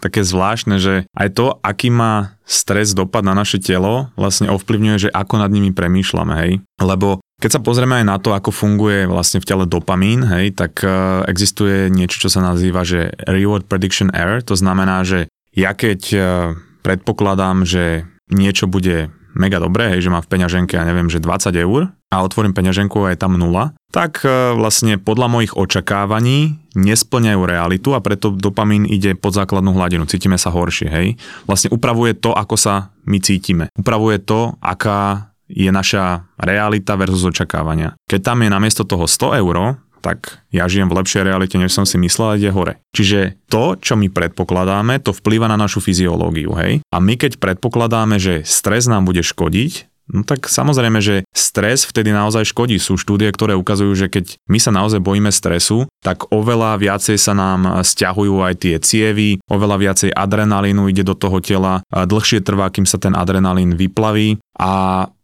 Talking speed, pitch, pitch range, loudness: 175 wpm, 100 Hz, 95-105 Hz, -15 LUFS